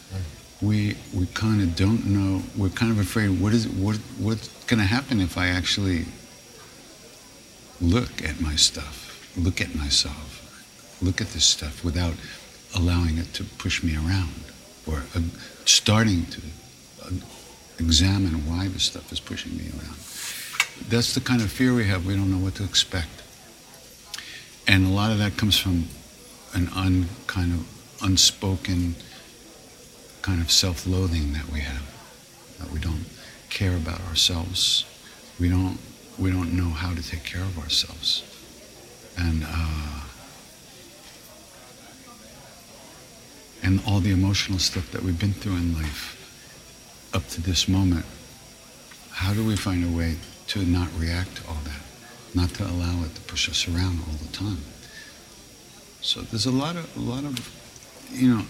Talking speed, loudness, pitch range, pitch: 150 wpm, -24 LUFS, 85-105 Hz, 90 Hz